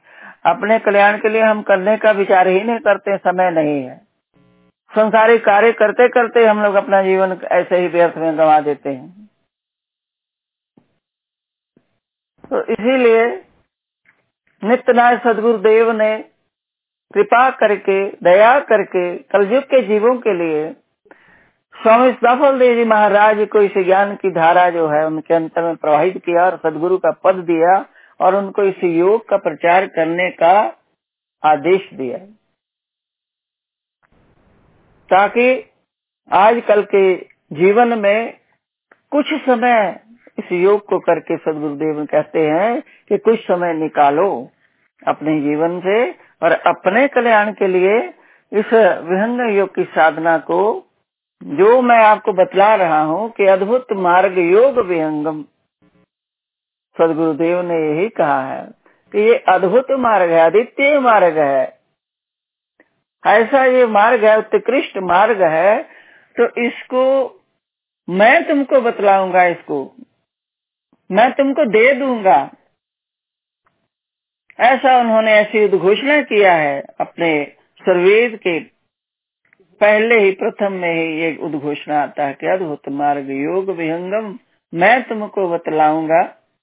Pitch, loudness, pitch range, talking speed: 200 Hz, -14 LUFS, 170-230 Hz, 125 wpm